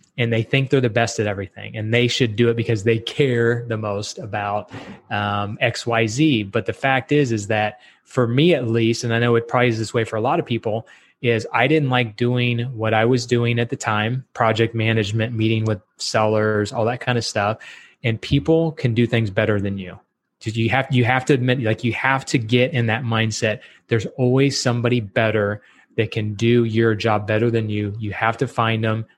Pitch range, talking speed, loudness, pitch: 110-125 Hz, 220 wpm, -20 LUFS, 115 Hz